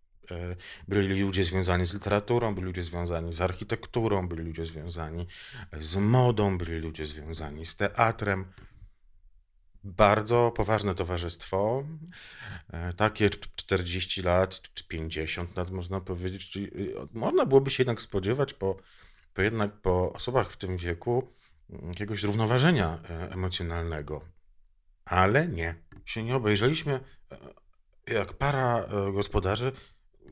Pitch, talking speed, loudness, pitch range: 95 Hz, 110 wpm, -29 LUFS, 85-110 Hz